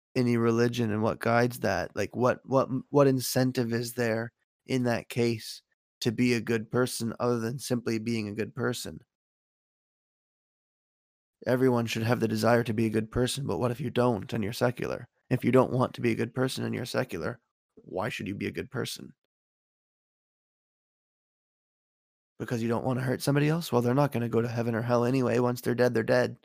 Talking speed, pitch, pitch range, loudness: 200 wpm, 120 Hz, 115-125 Hz, -28 LUFS